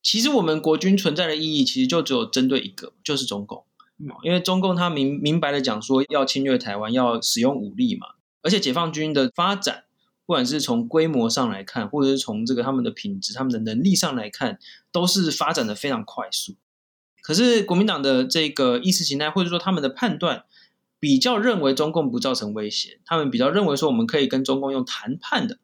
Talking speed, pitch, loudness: 330 characters per minute, 175 Hz, -22 LUFS